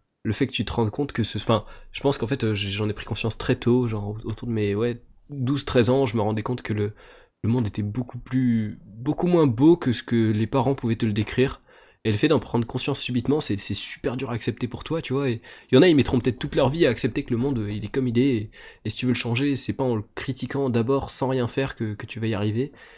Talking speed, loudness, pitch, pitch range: 285 wpm, -24 LUFS, 120 Hz, 110-135 Hz